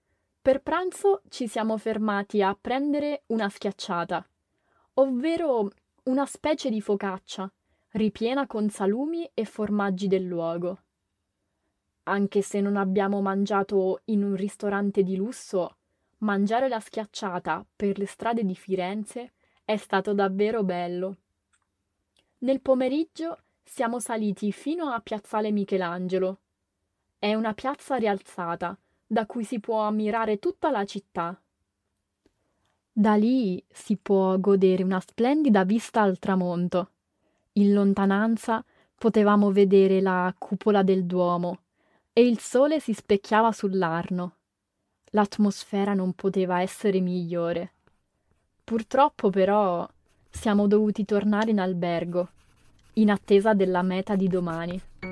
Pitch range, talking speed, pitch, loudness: 185-225 Hz, 115 wpm, 200 Hz, -26 LUFS